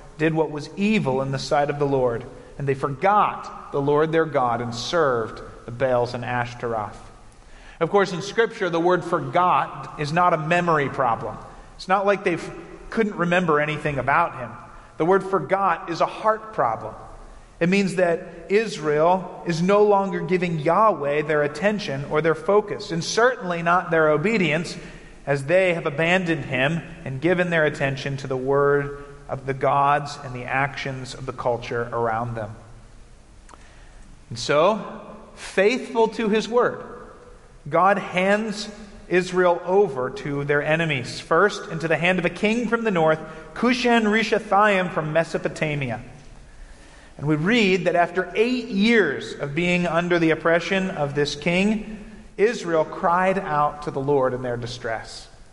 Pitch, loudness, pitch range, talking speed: 165 Hz, -22 LUFS, 140-190 Hz, 155 wpm